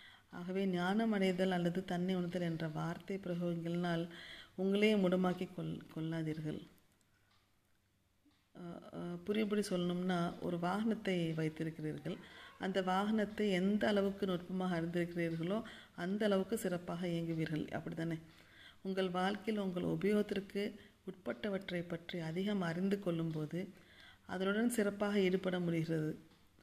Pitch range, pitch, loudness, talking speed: 170-195 Hz, 180 Hz, -38 LUFS, 95 wpm